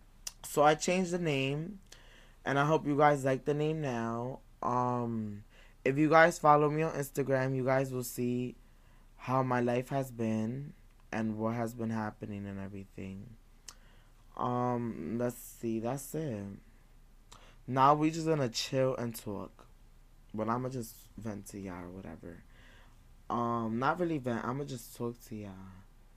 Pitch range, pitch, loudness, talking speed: 110-135 Hz, 120 Hz, -32 LUFS, 155 wpm